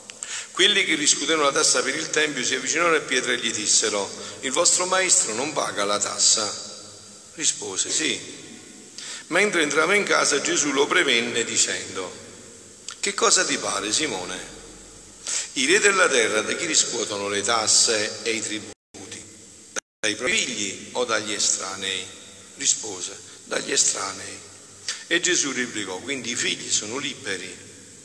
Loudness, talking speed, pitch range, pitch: -21 LUFS, 140 wpm, 100-110 Hz, 105 Hz